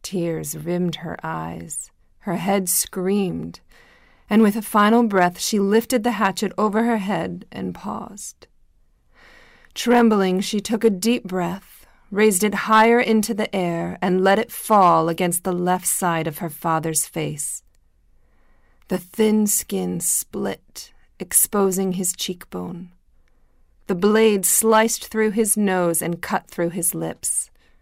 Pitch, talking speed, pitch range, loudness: 185 Hz, 135 wpm, 165-215 Hz, -20 LUFS